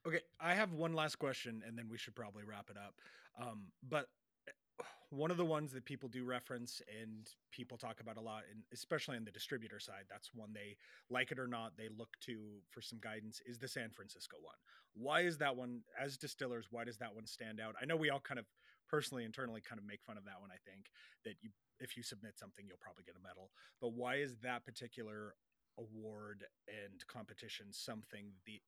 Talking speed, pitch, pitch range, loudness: 220 wpm, 115 Hz, 110-130 Hz, -46 LUFS